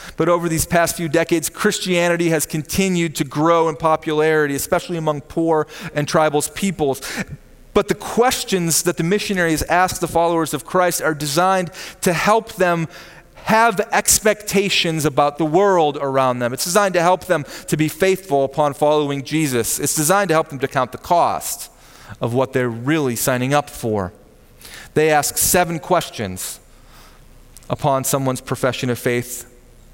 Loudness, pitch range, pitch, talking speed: -18 LUFS, 135-175 Hz, 155 Hz, 155 wpm